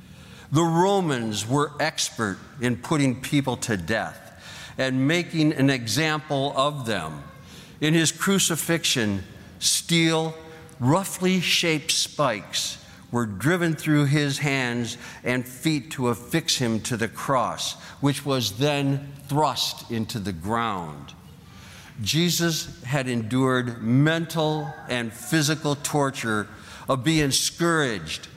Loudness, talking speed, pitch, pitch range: -24 LUFS, 110 wpm, 140 Hz, 120-160 Hz